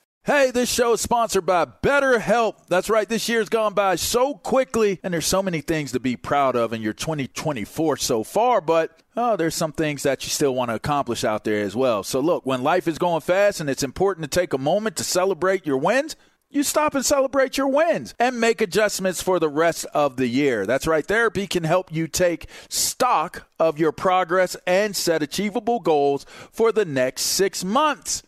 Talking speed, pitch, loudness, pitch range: 210 wpm, 185 Hz, -21 LUFS, 155-225 Hz